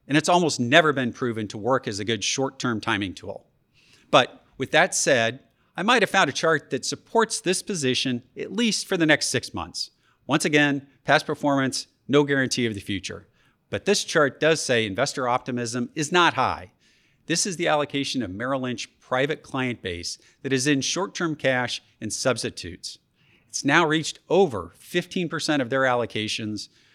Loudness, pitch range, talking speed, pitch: -23 LUFS, 120-155 Hz, 180 wpm, 135 Hz